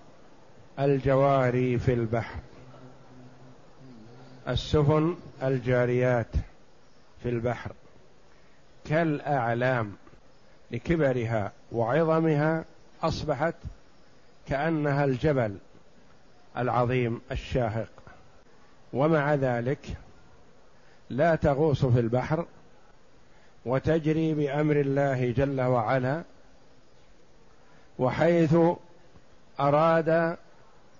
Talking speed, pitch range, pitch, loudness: 55 wpm, 125-155 Hz, 135 Hz, -26 LUFS